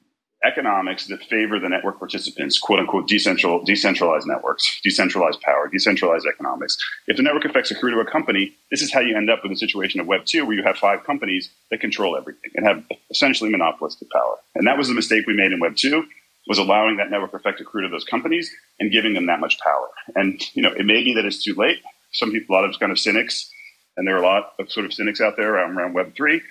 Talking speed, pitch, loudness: 240 wpm, 270 Hz, -20 LUFS